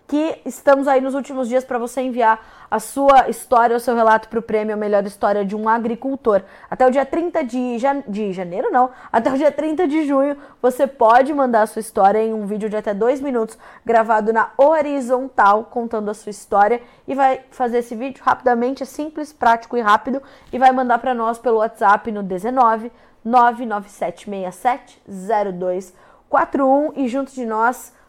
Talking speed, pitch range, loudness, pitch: 180 wpm, 220-270 Hz, -18 LUFS, 240 Hz